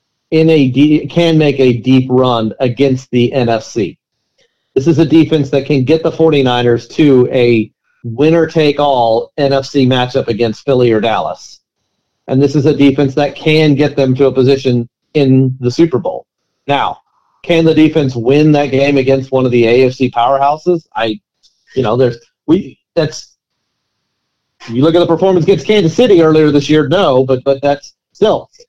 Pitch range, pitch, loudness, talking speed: 130-155 Hz, 140 Hz, -11 LUFS, 165 wpm